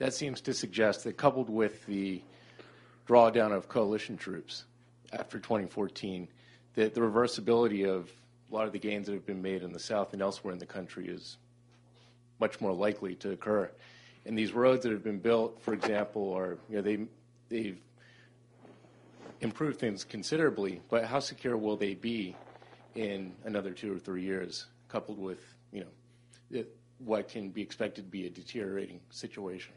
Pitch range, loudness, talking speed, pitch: 100-120 Hz, -33 LUFS, 165 wpm, 110 Hz